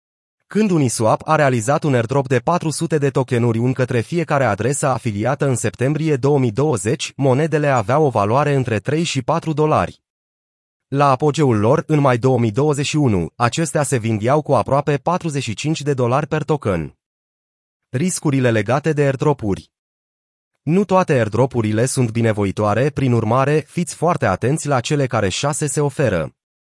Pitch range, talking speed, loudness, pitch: 115-150 Hz, 140 wpm, -18 LUFS, 135 Hz